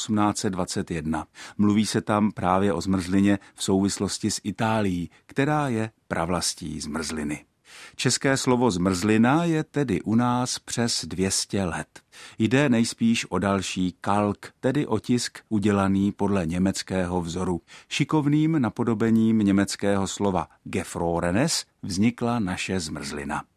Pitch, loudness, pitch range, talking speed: 100 Hz, -25 LUFS, 95-115 Hz, 110 wpm